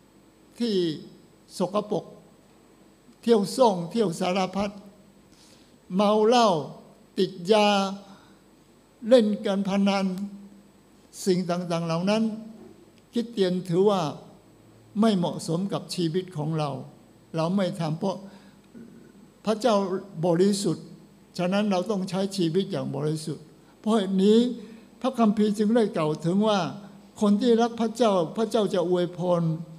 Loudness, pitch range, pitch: -25 LUFS, 180-215 Hz, 195 Hz